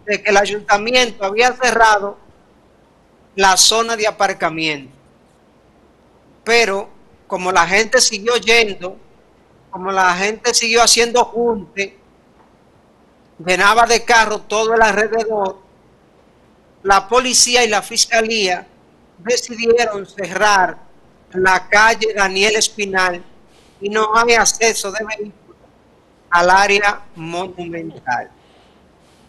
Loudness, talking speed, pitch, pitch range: -14 LUFS, 100 wpm, 210 Hz, 190-230 Hz